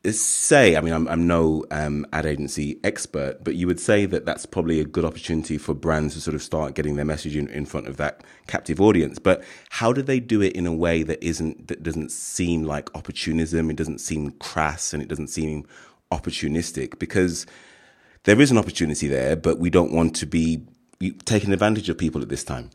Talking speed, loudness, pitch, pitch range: 210 wpm, -23 LUFS, 80 Hz, 75-85 Hz